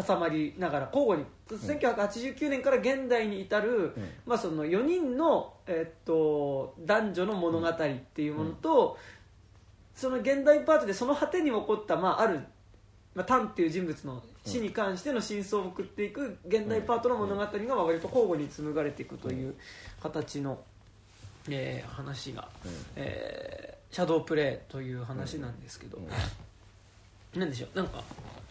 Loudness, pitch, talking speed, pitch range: -31 LUFS, 165 Hz, 285 characters per minute, 130-220 Hz